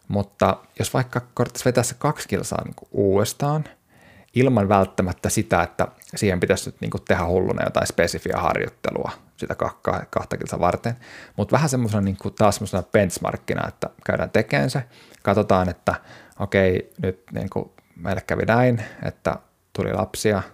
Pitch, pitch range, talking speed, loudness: 105 Hz, 95-120 Hz, 145 wpm, -23 LUFS